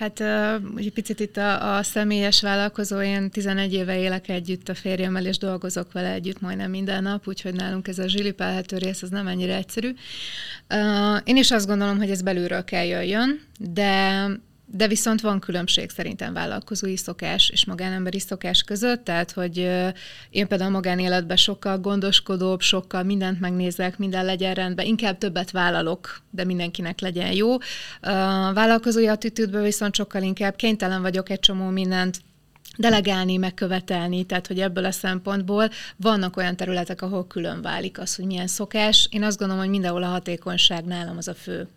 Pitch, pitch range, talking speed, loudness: 190 Hz, 185-205 Hz, 165 wpm, -23 LUFS